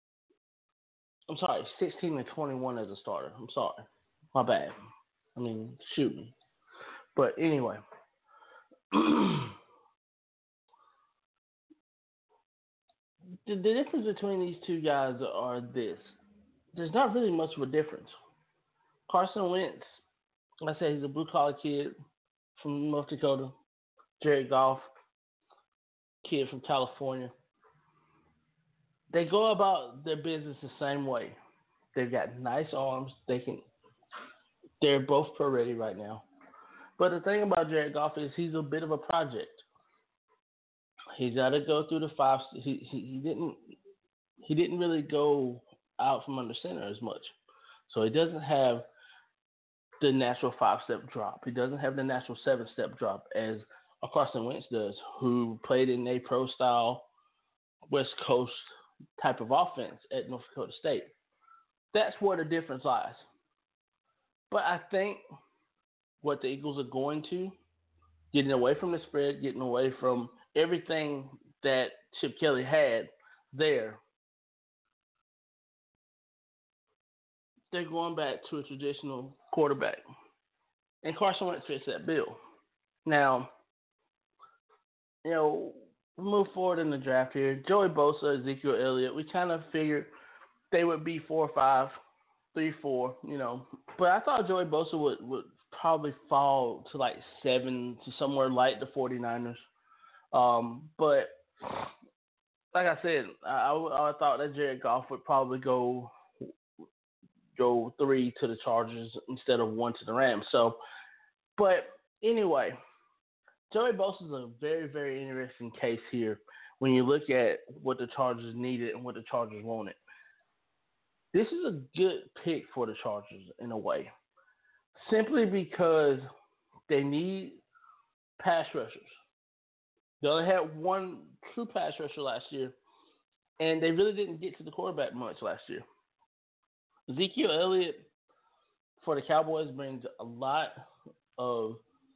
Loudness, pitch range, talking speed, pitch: -31 LUFS, 130-185 Hz, 135 wpm, 150 Hz